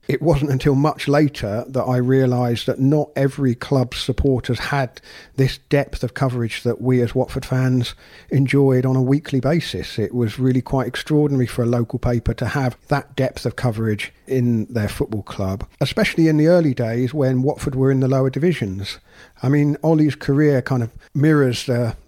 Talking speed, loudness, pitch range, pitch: 180 wpm, -19 LUFS, 120-140 Hz, 130 Hz